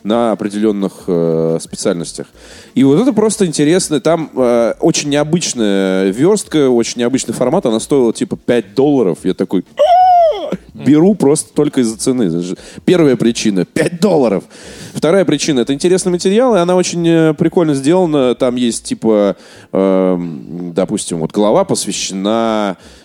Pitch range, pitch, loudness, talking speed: 100-160 Hz, 125 Hz, -13 LUFS, 130 wpm